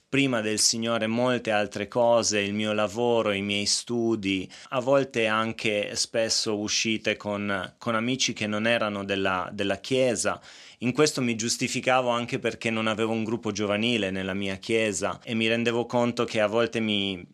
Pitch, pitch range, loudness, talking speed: 110 Hz, 105-120 Hz, -25 LUFS, 165 wpm